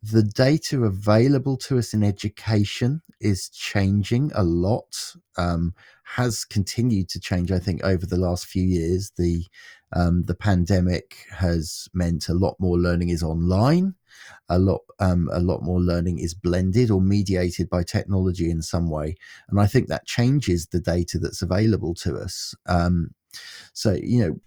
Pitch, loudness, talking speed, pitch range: 95 Hz, -23 LUFS, 160 wpm, 85-105 Hz